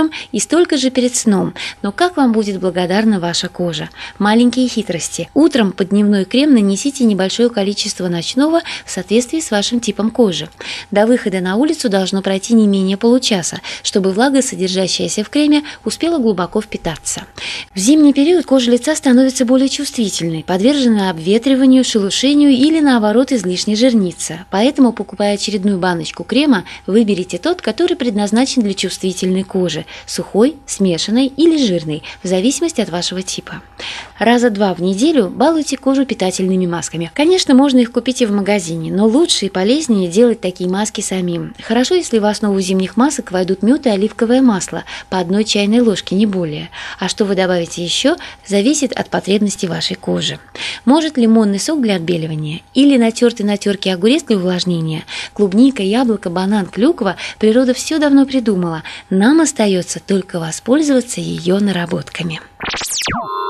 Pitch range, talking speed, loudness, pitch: 185-255 Hz, 150 wpm, -15 LUFS, 210 Hz